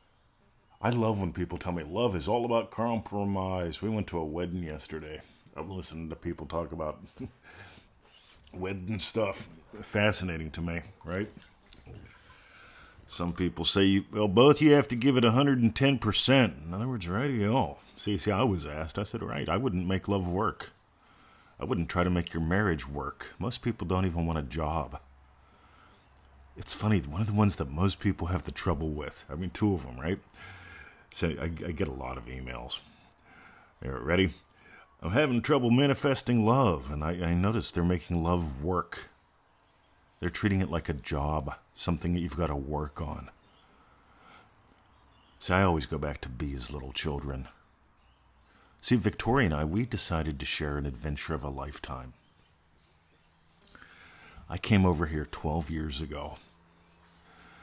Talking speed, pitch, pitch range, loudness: 170 wpm, 85 Hz, 75-100 Hz, -30 LUFS